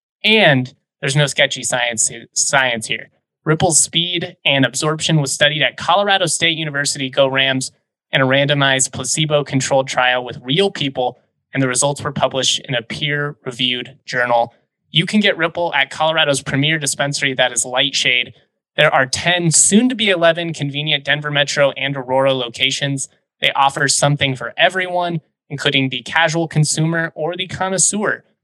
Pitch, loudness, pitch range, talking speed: 145 Hz, -16 LUFS, 135-165 Hz, 155 wpm